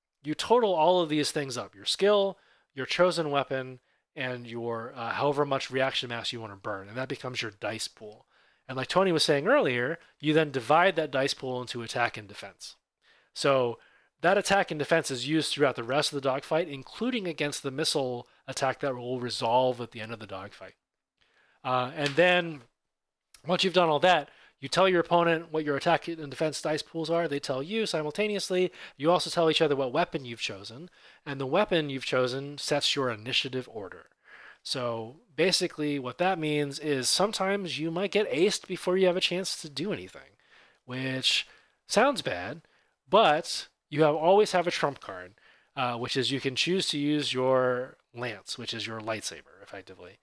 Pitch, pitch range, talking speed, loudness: 145 Hz, 125-165 Hz, 190 wpm, -28 LUFS